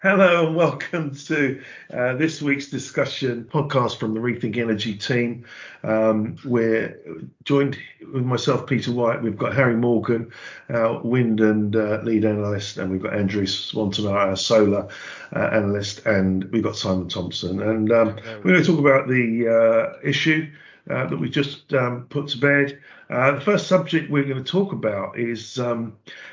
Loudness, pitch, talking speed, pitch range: -21 LUFS, 120 Hz, 170 wpm, 110-140 Hz